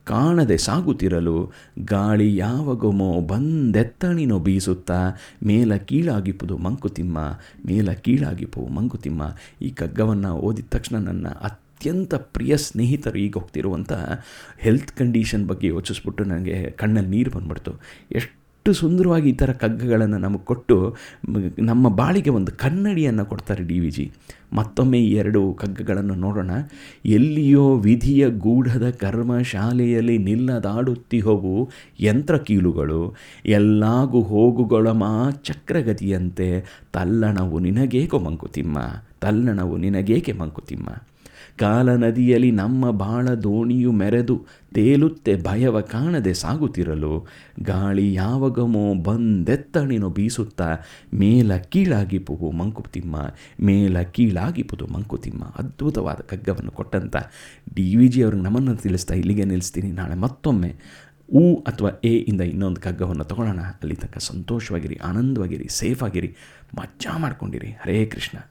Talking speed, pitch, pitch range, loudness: 105 wpm, 105 Hz, 95-125 Hz, -21 LUFS